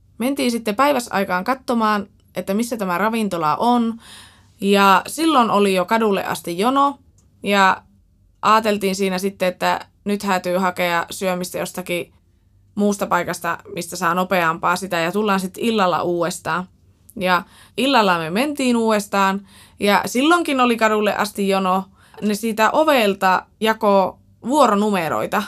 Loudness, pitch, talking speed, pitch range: -19 LUFS, 195 Hz, 125 wpm, 180-220 Hz